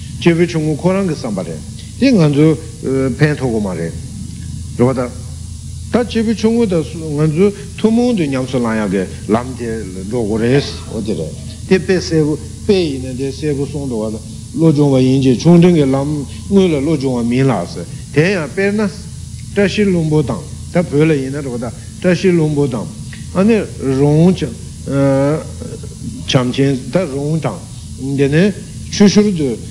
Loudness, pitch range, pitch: -15 LUFS, 125-175 Hz, 140 Hz